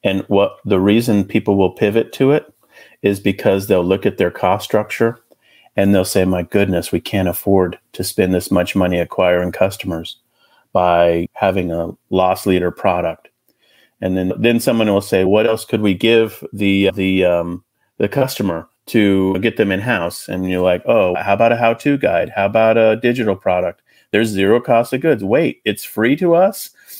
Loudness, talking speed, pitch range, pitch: -16 LUFS, 185 wpm, 90-110 Hz, 100 Hz